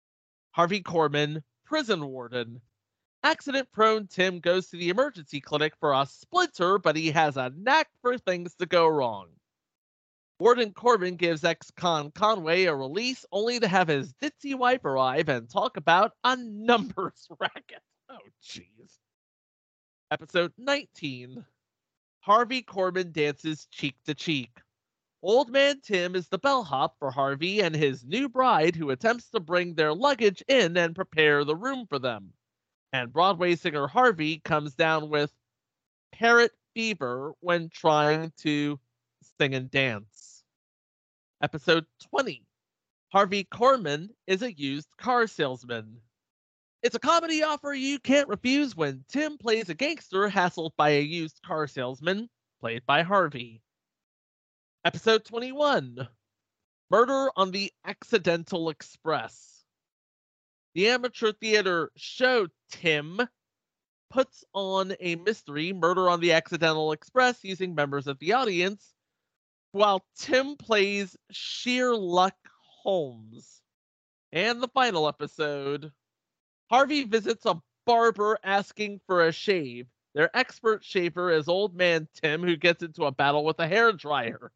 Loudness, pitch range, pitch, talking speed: -26 LUFS, 150-225 Hz, 175 Hz, 130 wpm